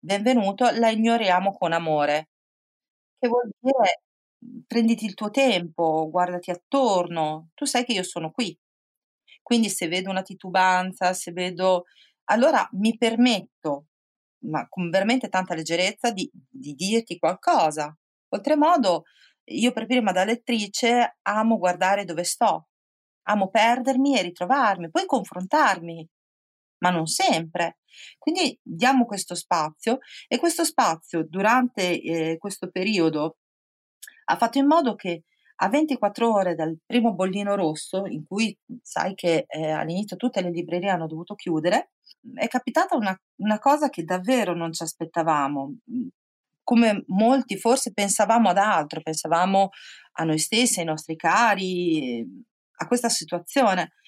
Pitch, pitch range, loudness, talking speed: 195 Hz, 170-240 Hz, -23 LUFS, 135 wpm